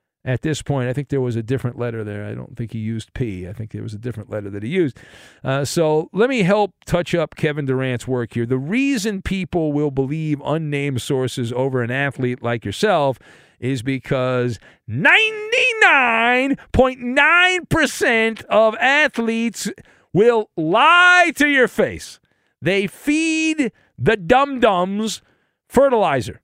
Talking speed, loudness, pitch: 150 wpm, -18 LUFS, 155 Hz